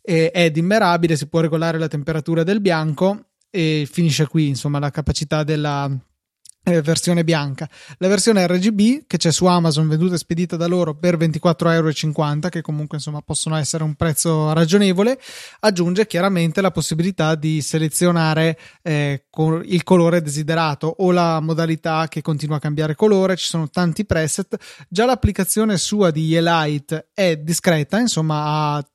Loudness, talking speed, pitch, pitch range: -18 LUFS, 150 wpm, 165 Hz, 155-180 Hz